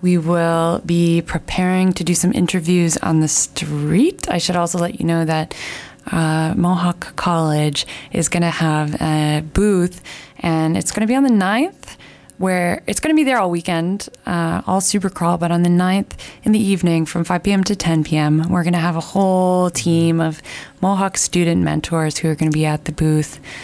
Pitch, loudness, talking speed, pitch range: 175 Hz, -17 LUFS, 200 wpm, 160-185 Hz